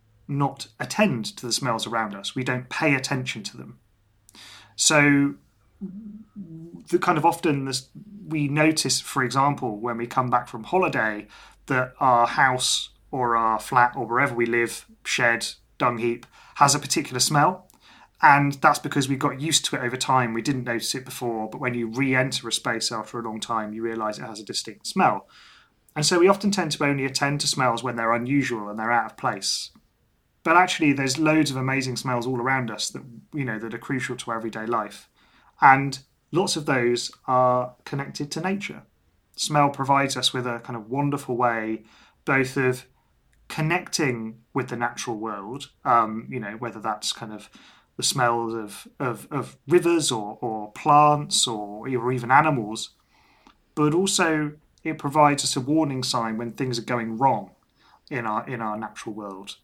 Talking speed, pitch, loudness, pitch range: 180 wpm, 130 Hz, -23 LUFS, 115-145 Hz